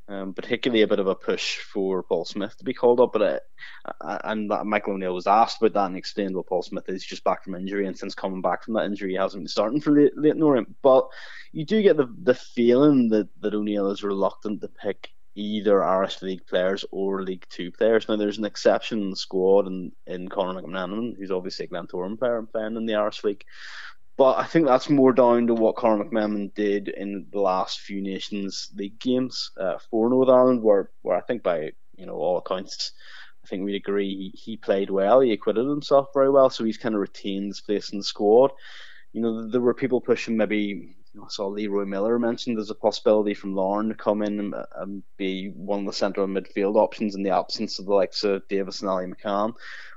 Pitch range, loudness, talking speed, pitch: 95-115 Hz, -24 LUFS, 230 wpm, 105 Hz